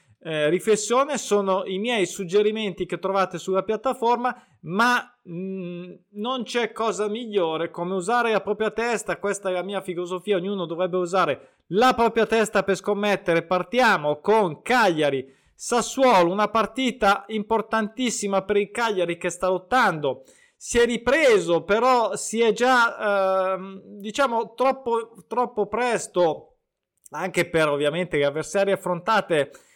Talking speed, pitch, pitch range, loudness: 130 wpm, 205 Hz, 185-230 Hz, -23 LUFS